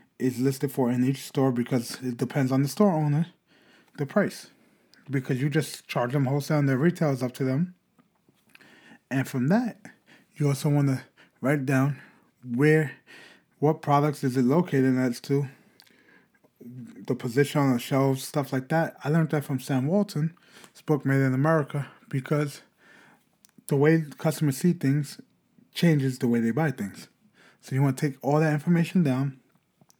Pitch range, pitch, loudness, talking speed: 130-155 Hz, 140 Hz, -26 LUFS, 170 wpm